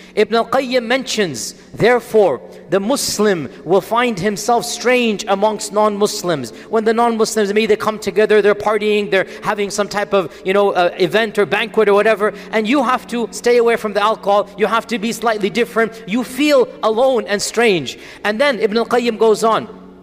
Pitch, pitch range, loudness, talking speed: 215 Hz, 205-230 Hz, -16 LUFS, 180 wpm